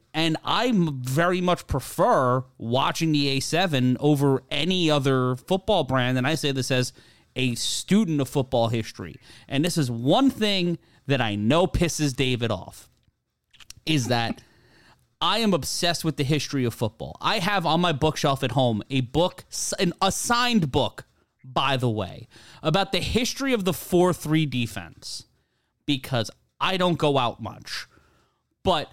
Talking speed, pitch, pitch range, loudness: 150 wpm, 140 Hz, 125-175 Hz, -24 LUFS